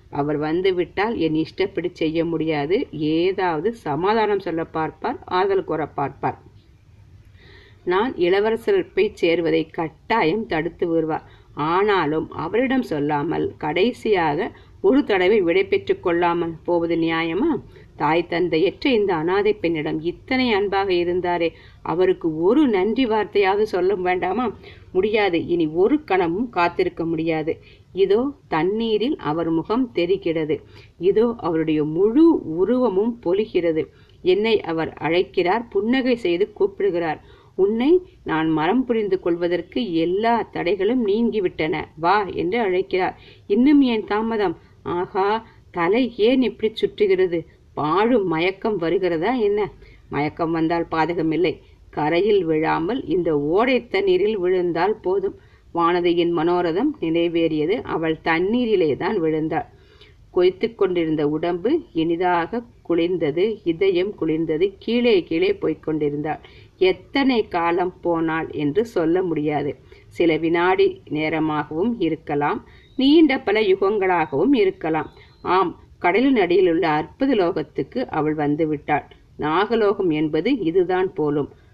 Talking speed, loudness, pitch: 105 wpm, -21 LUFS, 200 Hz